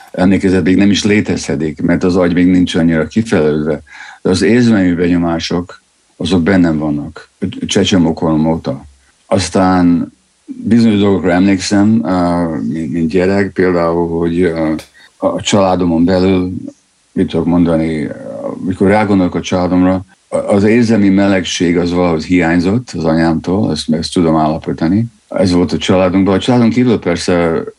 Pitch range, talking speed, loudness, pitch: 85-95 Hz, 125 wpm, -12 LUFS, 90 Hz